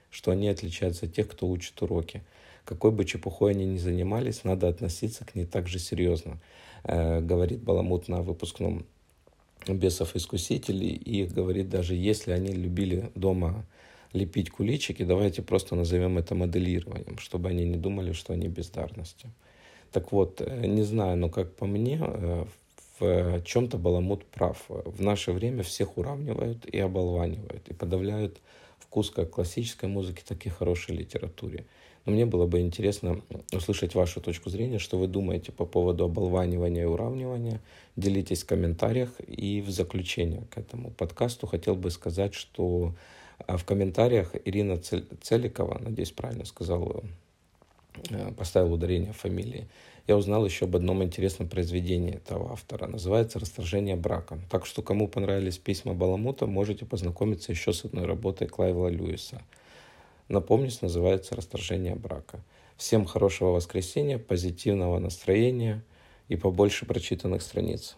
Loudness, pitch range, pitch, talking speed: -29 LUFS, 90-105 Hz, 95 Hz, 140 wpm